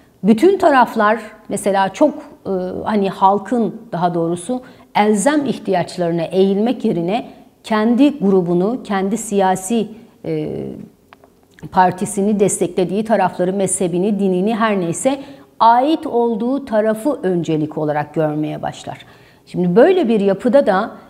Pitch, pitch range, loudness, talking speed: 200 Hz, 180-230 Hz, -17 LUFS, 105 wpm